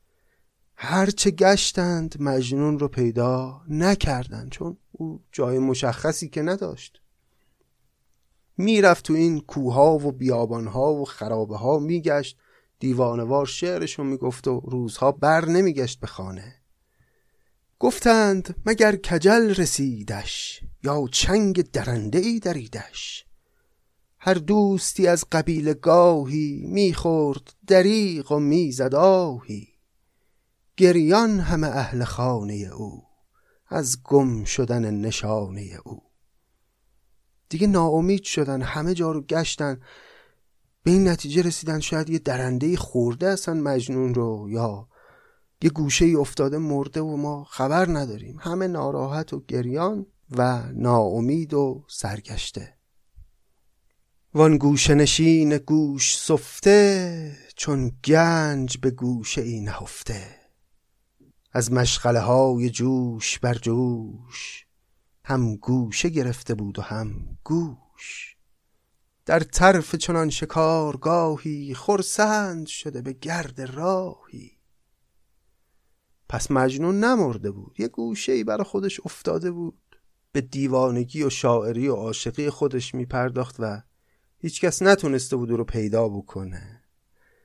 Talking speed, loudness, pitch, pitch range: 105 wpm, -22 LUFS, 140 Hz, 120-165 Hz